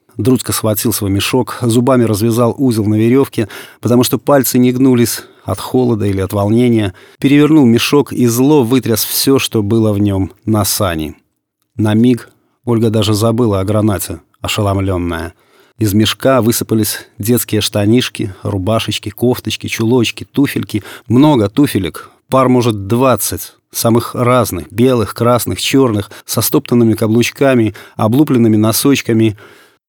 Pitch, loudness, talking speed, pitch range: 115 Hz, -13 LUFS, 125 wpm, 105-125 Hz